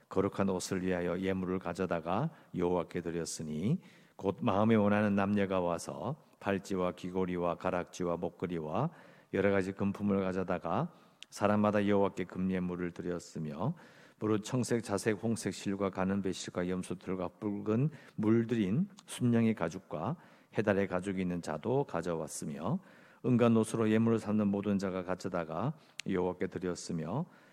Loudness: -34 LUFS